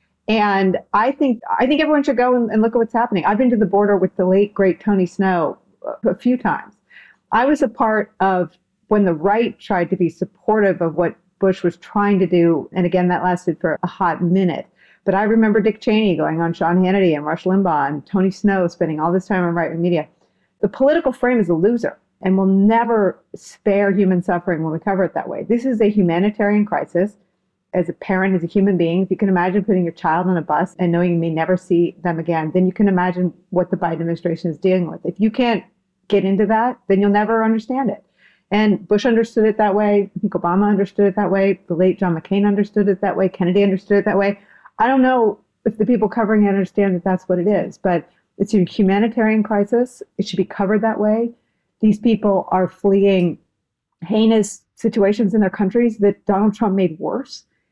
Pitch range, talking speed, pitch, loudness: 180-215 Hz, 220 wpm, 195 Hz, -18 LUFS